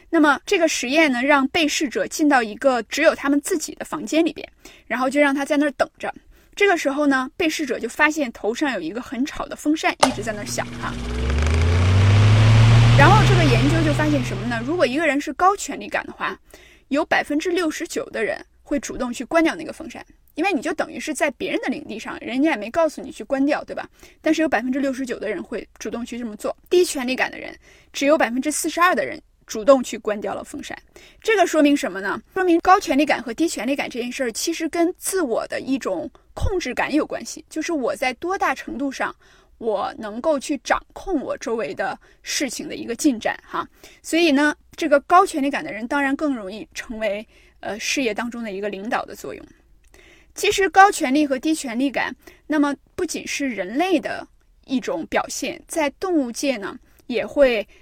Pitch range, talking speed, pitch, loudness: 255-325 Hz, 310 characters per minute, 290 Hz, -21 LUFS